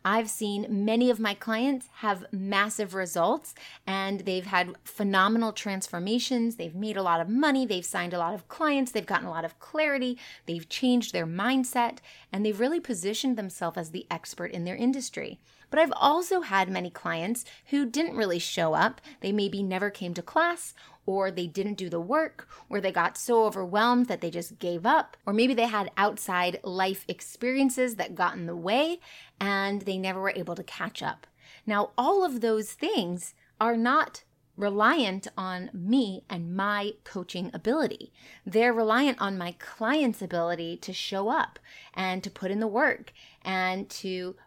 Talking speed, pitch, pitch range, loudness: 175 wpm, 205 Hz, 185-240 Hz, -28 LUFS